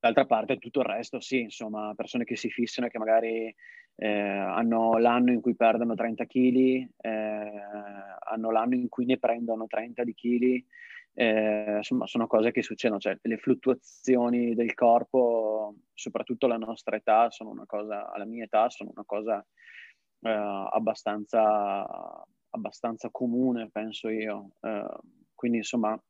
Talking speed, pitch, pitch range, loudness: 145 wpm, 115 Hz, 110-120 Hz, -28 LUFS